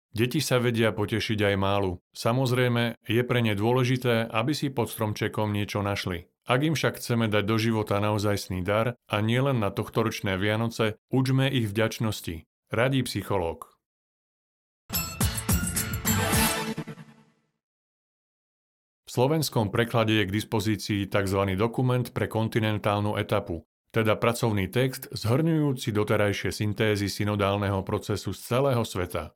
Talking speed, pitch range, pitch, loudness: 120 wpm, 105-120 Hz, 110 Hz, -26 LUFS